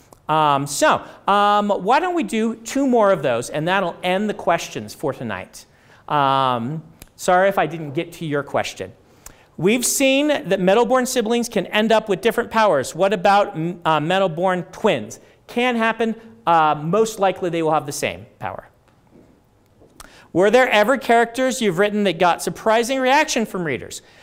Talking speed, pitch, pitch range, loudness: 165 wpm, 195 Hz, 170-230 Hz, -19 LUFS